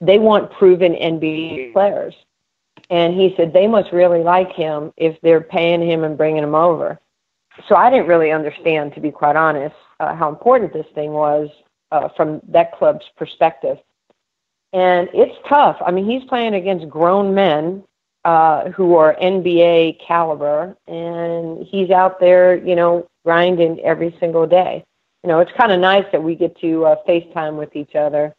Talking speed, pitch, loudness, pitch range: 170 wpm, 170 Hz, -15 LUFS, 160-185 Hz